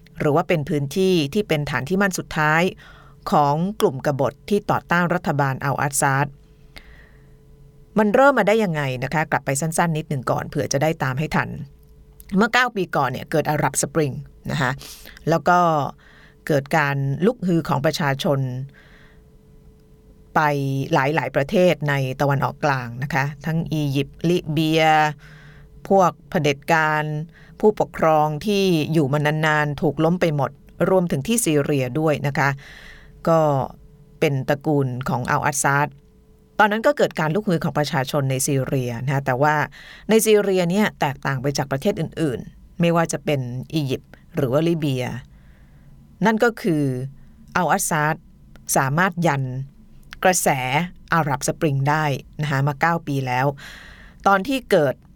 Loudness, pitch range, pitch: -21 LUFS, 140-170 Hz, 150 Hz